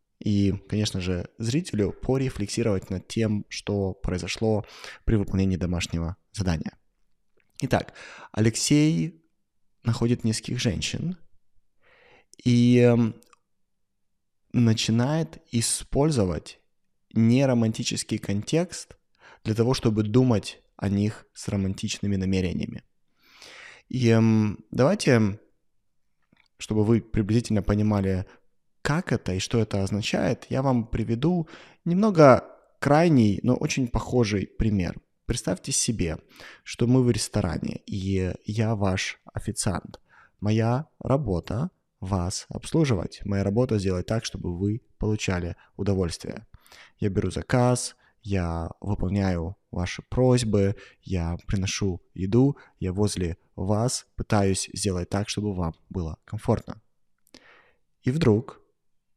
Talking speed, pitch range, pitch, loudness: 100 wpm, 95-120 Hz, 105 Hz, -25 LUFS